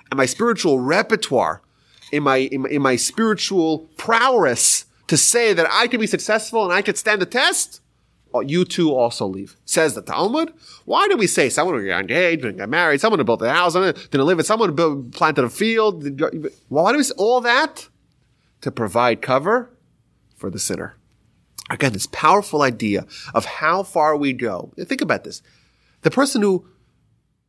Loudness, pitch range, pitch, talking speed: -18 LUFS, 135-220 Hz, 175 Hz, 190 wpm